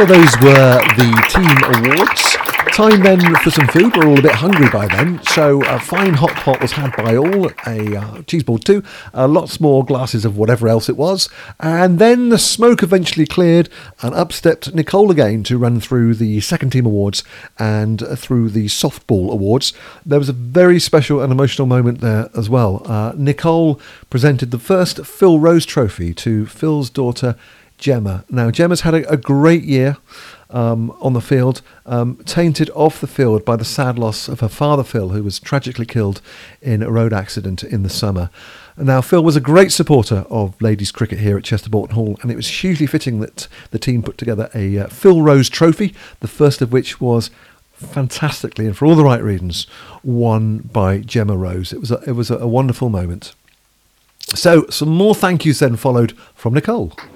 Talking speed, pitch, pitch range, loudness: 195 wpm, 130 Hz, 110-155 Hz, -14 LUFS